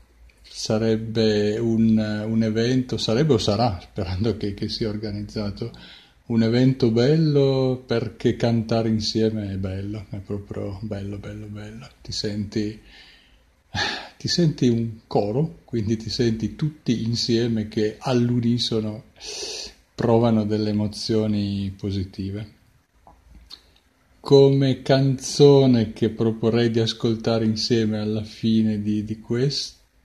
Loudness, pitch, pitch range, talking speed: -22 LUFS, 110 Hz, 105-120 Hz, 110 wpm